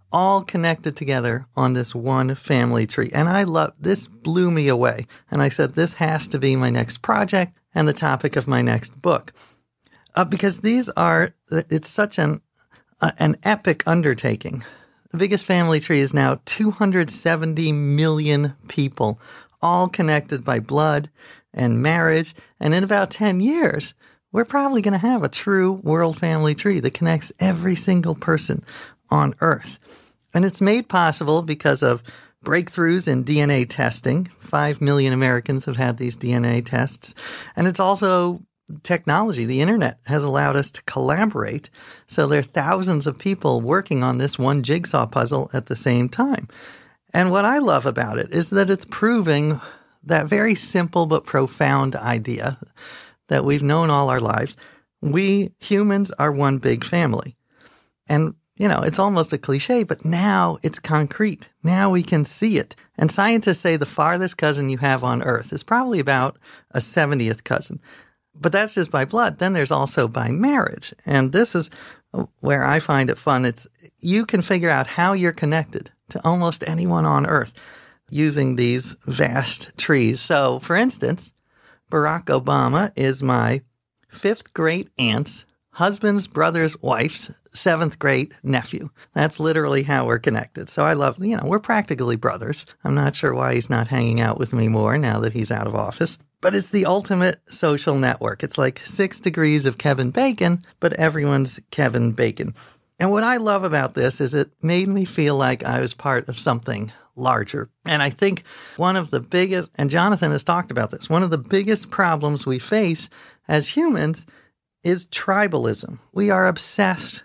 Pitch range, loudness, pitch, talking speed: 135-185 Hz, -20 LUFS, 155 Hz, 170 wpm